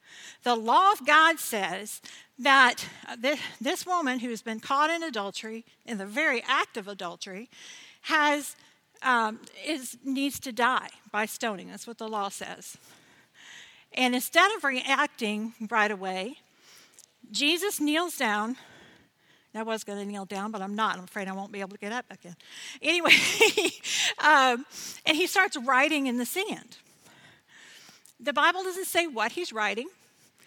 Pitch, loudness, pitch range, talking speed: 245 Hz, -26 LUFS, 215-300 Hz, 150 wpm